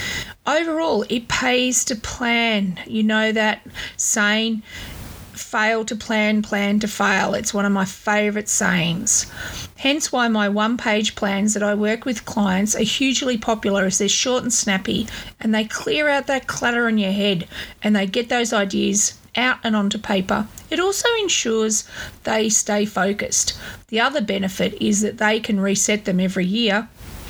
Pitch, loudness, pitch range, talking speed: 215 Hz, -20 LUFS, 200-235 Hz, 165 wpm